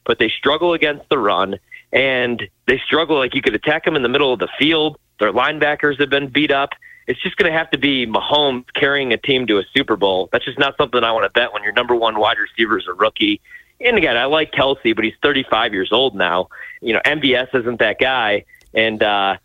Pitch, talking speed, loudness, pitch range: 140 Hz, 240 wpm, -17 LUFS, 115-150 Hz